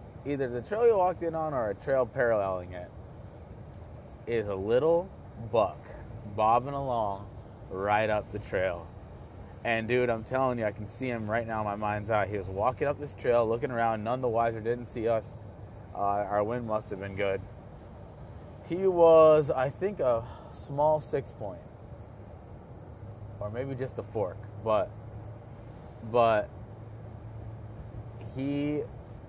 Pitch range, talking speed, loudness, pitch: 105-125 Hz, 150 wpm, -29 LUFS, 115 Hz